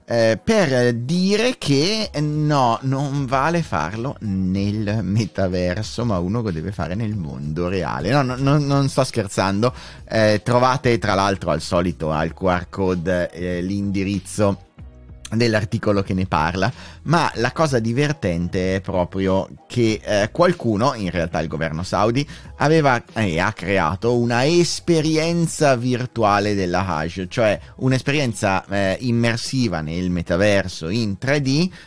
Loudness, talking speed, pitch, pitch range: -20 LUFS, 130 wpm, 105 Hz, 90-130 Hz